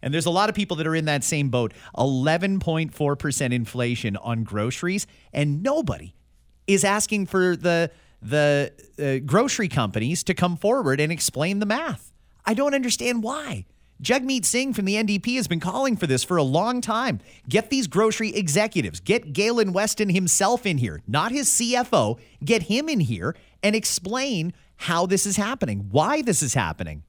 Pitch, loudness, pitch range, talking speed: 175 Hz, -23 LUFS, 140-215 Hz, 175 wpm